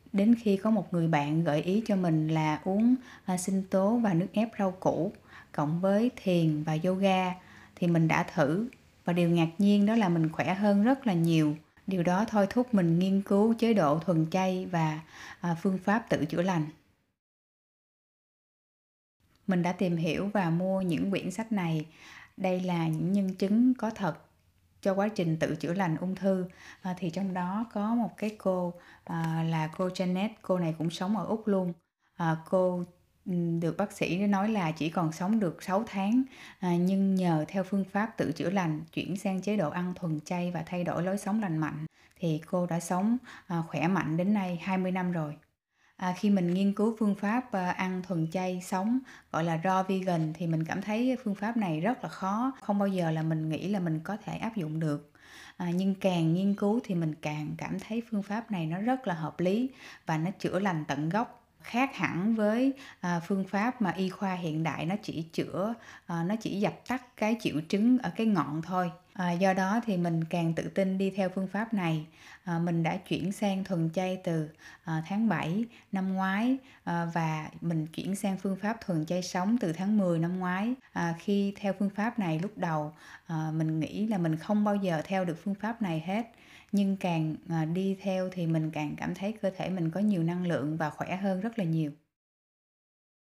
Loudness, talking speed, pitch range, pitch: -30 LUFS, 200 wpm, 165-200 Hz, 185 Hz